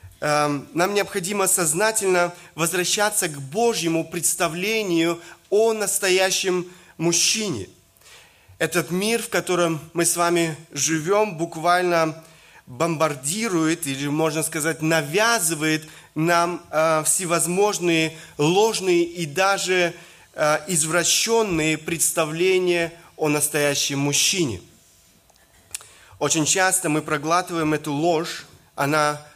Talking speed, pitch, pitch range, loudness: 85 wpm, 170 Hz, 155-185 Hz, -21 LUFS